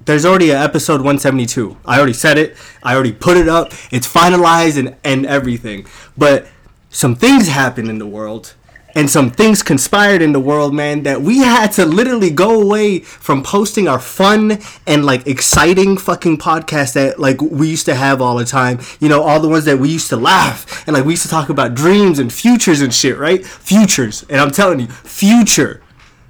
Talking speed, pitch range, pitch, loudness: 200 wpm, 135-180 Hz, 150 Hz, -12 LUFS